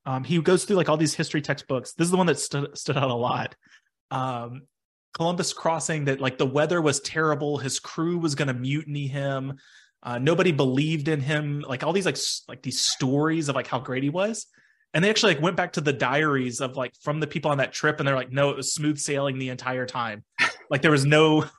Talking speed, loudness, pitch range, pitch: 240 wpm, -25 LUFS, 135-160 Hz, 145 Hz